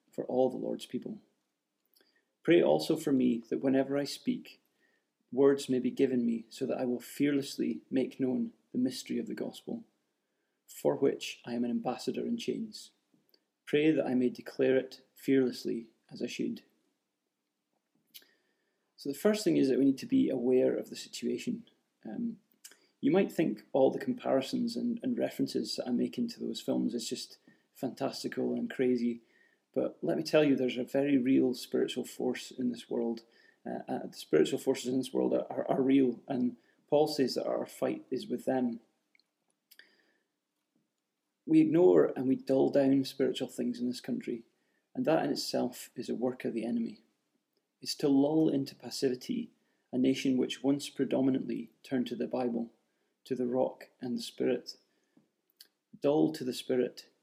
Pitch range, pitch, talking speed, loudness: 120-140 Hz, 130 Hz, 170 wpm, -32 LUFS